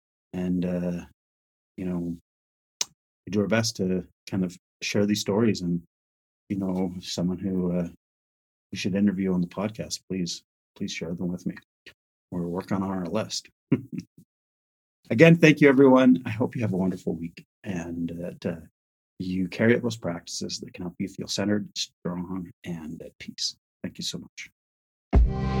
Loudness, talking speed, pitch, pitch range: -26 LUFS, 165 wpm, 90 Hz, 85-95 Hz